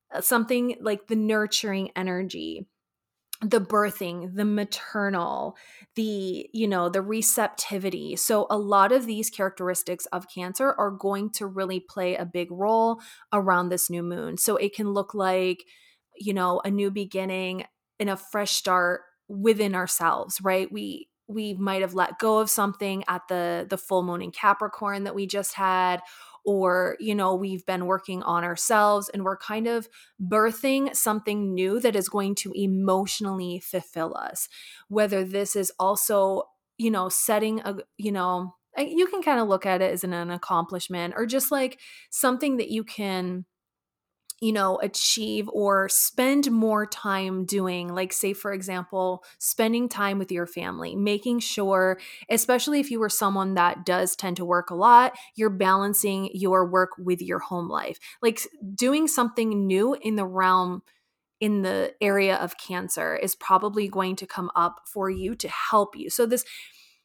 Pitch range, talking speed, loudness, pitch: 185-215 Hz, 165 wpm, -25 LUFS, 195 Hz